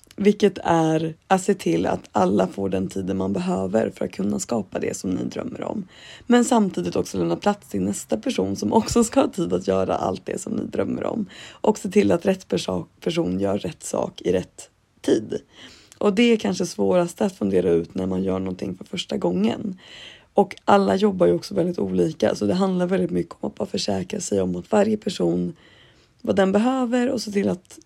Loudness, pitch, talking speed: -23 LUFS, 170 Hz, 210 wpm